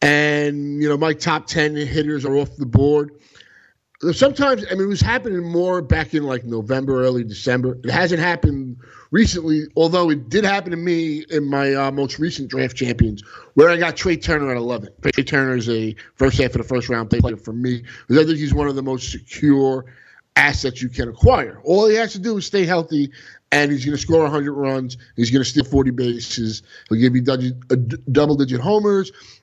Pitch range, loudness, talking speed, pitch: 125-160 Hz, -19 LUFS, 205 wpm, 140 Hz